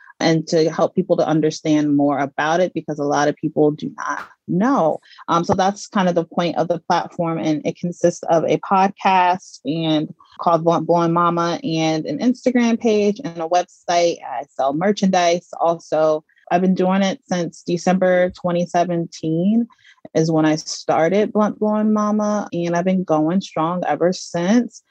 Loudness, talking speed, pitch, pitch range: -19 LUFS, 170 wpm, 175 Hz, 160-190 Hz